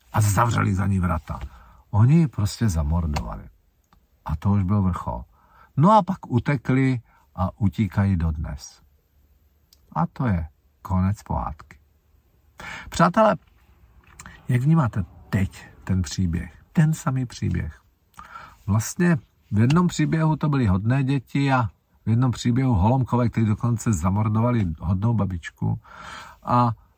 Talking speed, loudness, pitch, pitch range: 120 wpm, -23 LUFS, 105 Hz, 85-125 Hz